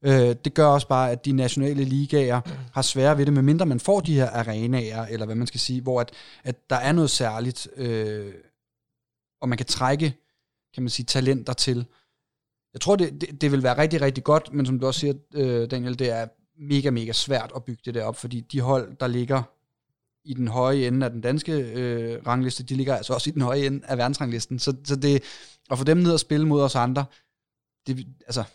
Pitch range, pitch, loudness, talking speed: 120-140 Hz, 130 Hz, -24 LUFS, 220 wpm